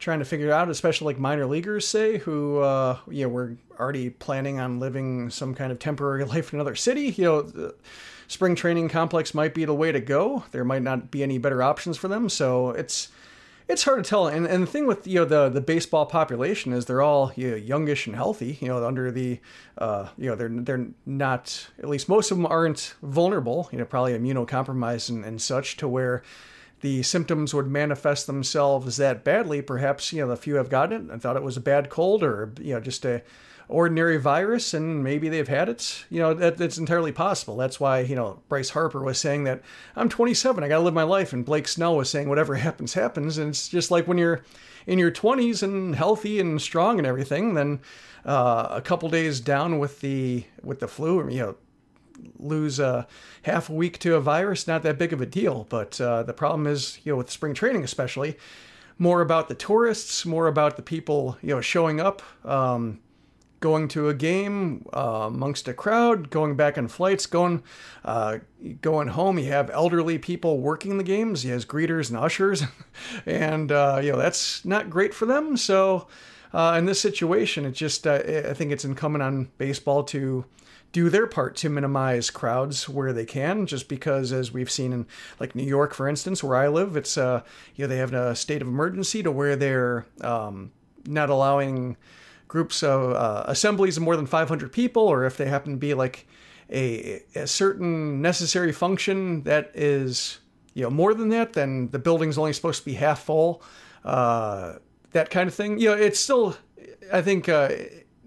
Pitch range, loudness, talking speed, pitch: 130-170 Hz, -24 LUFS, 205 wpm, 150 Hz